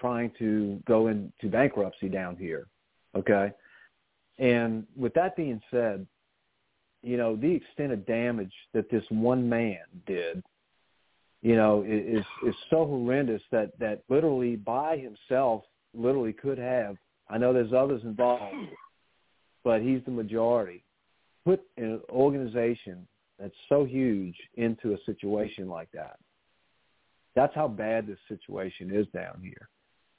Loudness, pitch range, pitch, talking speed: -29 LUFS, 105-125 Hz, 115 Hz, 130 wpm